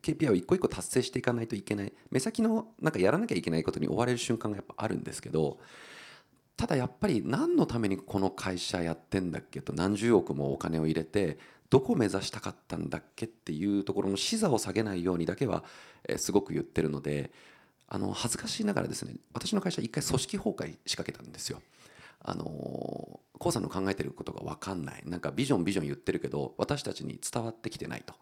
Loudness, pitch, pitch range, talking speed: -32 LUFS, 95 Hz, 85-115 Hz, 440 characters per minute